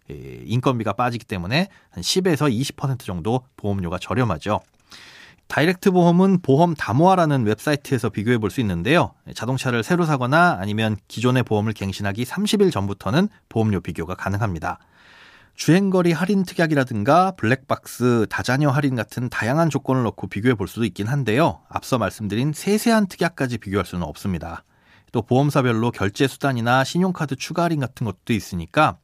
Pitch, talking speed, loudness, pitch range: 125 Hz, 375 characters per minute, -21 LUFS, 105-155 Hz